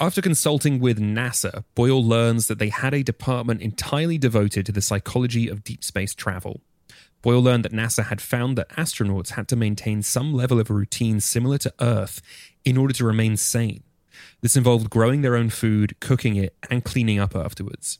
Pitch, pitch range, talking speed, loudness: 115 Hz, 105-125 Hz, 185 wpm, -22 LUFS